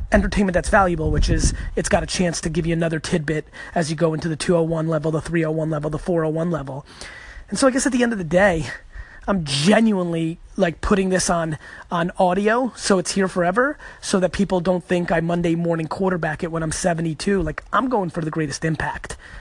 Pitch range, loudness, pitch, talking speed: 160-195 Hz, -21 LUFS, 175 Hz, 215 wpm